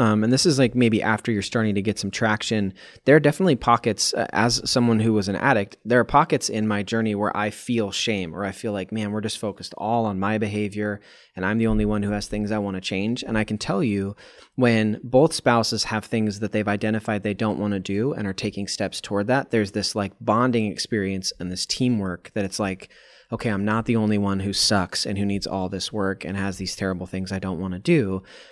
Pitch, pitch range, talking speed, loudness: 105 Hz, 100-115 Hz, 245 wpm, -23 LUFS